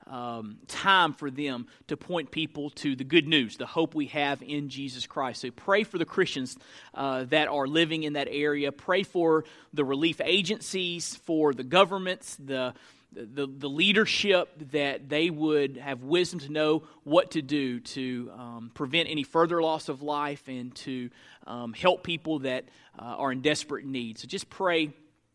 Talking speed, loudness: 175 wpm, -28 LUFS